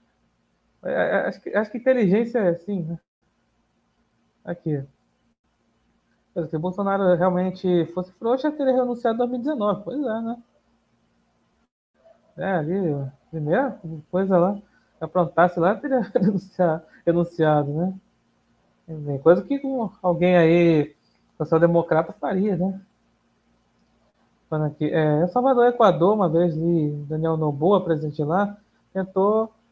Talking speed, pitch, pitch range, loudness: 105 wpm, 180 Hz, 165-210 Hz, -22 LUFS